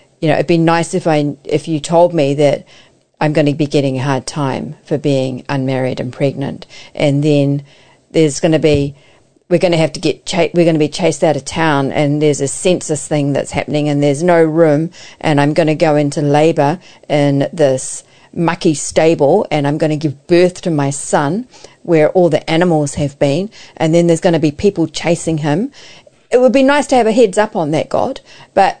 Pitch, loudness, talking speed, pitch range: 155 Hz, -14 LUFS, 215 wpm, 145-170 Hz